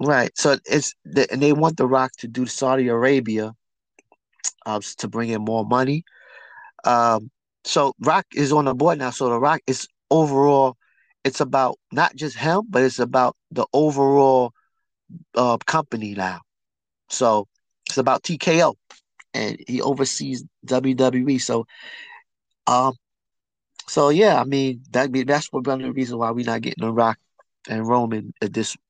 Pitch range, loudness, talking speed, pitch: 115-145 Hz, -21 LUFS, 155 wpm, 130 Hz